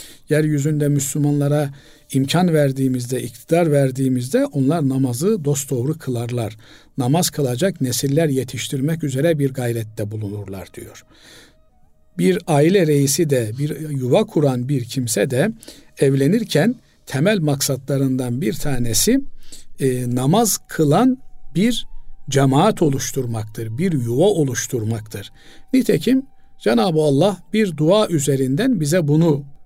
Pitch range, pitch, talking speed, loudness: 130-160 Hz, 140 Hz, 100 wpm, -19 LUFS